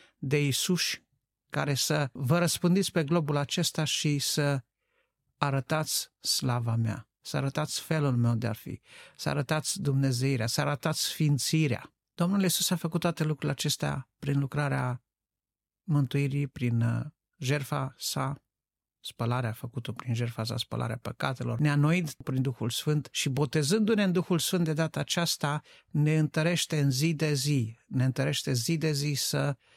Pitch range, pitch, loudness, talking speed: 130-155 Hz, 145 Hz, -29 LUFS, 145 wpm